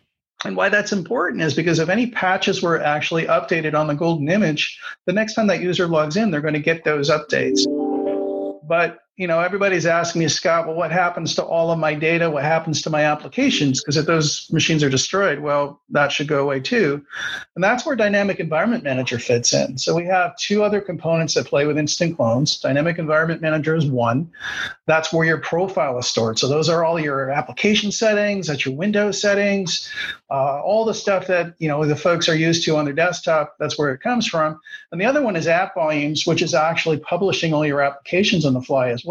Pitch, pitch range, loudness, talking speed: 165 Hz, 150-185 Hz, -19 LUFS, 215 wpm